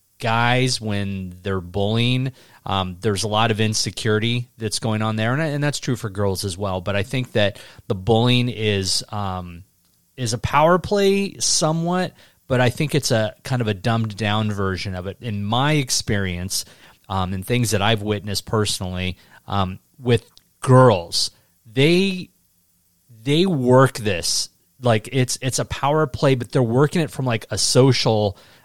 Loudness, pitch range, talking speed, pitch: -20 LUFS, 100-130 Hz, 165 wpm, 110 Hz